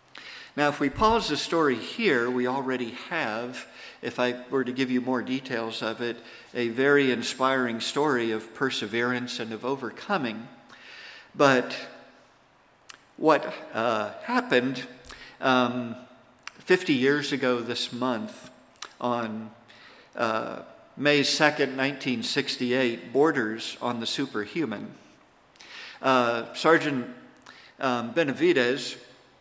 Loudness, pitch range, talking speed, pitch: -26 LUFS, 120-135 Hz, 105 wpm, 125 Hz